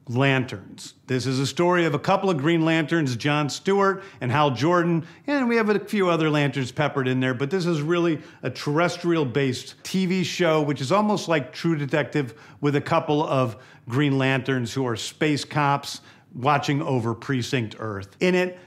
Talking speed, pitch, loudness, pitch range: 185 wpm, 145 Hz, -23 LUFS, 135-170 Hz